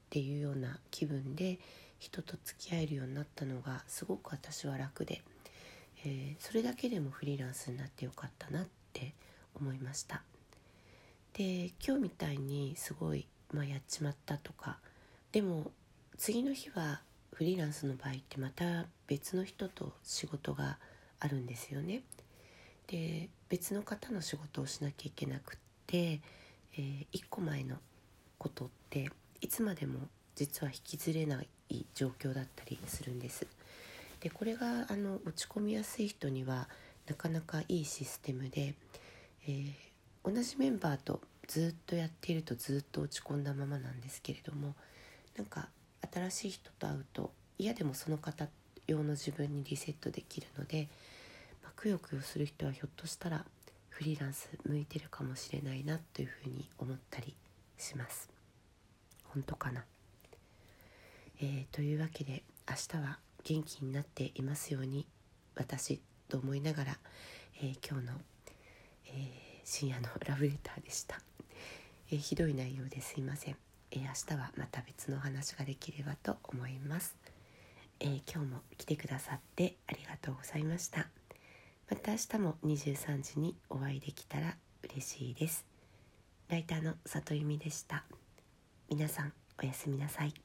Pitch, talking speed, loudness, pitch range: 145 Hz, 305 characters per minute, -41 LUFS, 130-160 Hz